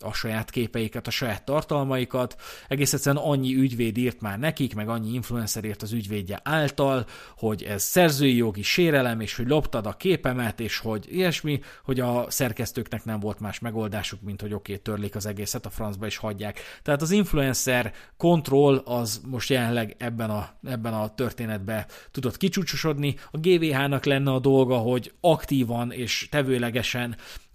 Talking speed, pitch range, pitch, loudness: 160 wpm, 110-140 Hz, 120 Hz, -26 LUFS